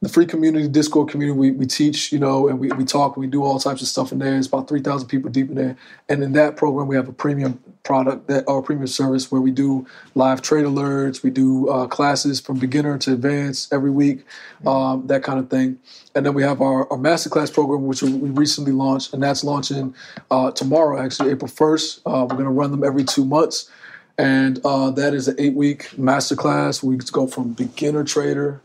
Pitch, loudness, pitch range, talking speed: 140 Hz, -19 LUFS, 130-145 Hz, 220 wpm